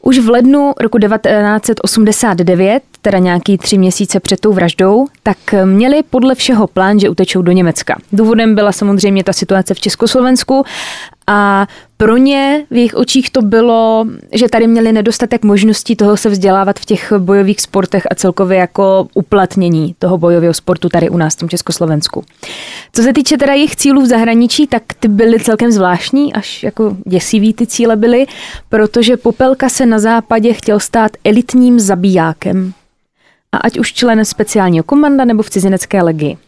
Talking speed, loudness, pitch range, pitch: 165 wpm, -10 LUFS, 190-235 Hz, 215 Hz